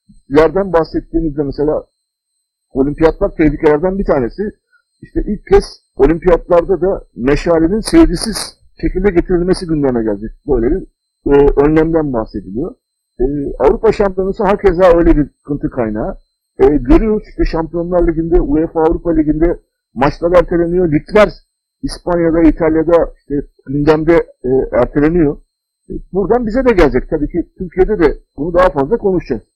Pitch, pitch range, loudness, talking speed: 165 Hz, 150-190 Hz, -14 LUFS, 125 wpm